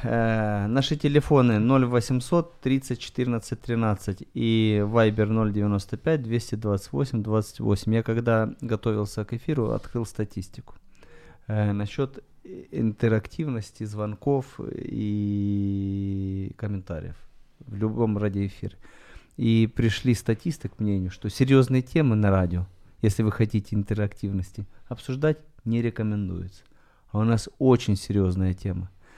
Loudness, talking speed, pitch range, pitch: -25 LUFS, 105 wpm, 100-120 Hz, 110 Hz